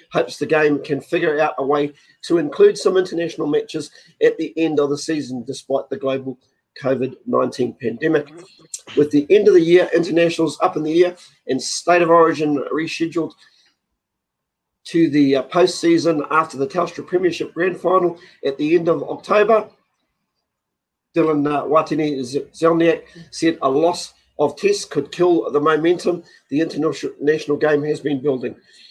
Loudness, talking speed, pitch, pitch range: -18 LUFS, 150 wpm, 160 Hz, 145-175 Hz